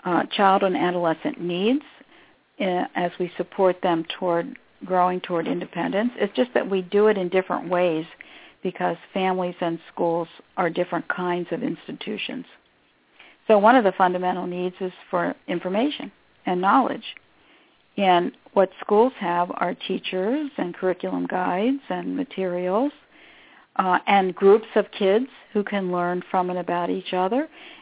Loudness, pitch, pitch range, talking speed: -23 LUFS, 185 Hz, 180-215 Hz, 145 wpm